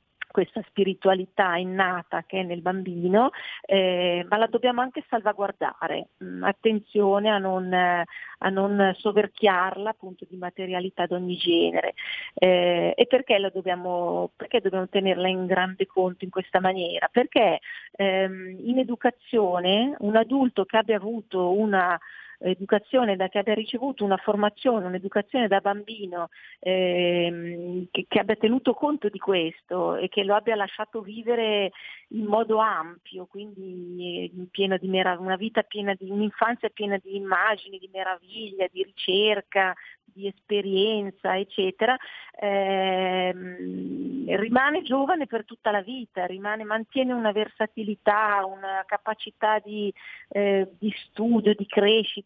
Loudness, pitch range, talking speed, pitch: -25 LUFS, 185-220 Hz, 130 wpm, 200 Hz